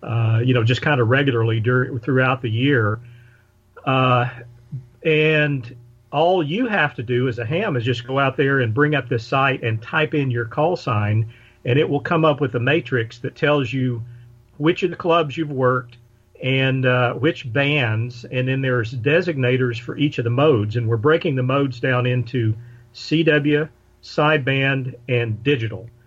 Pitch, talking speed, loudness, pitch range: 130 Hz, 180 wpm, -20 LUFS, 120-150 Hz